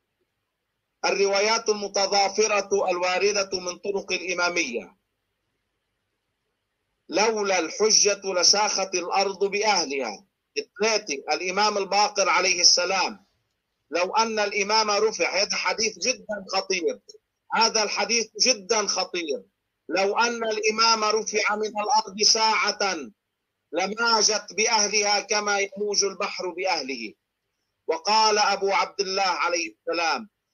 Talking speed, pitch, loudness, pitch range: 90 wpm, 205 Hz, -22 LUFS, 185-215 Hz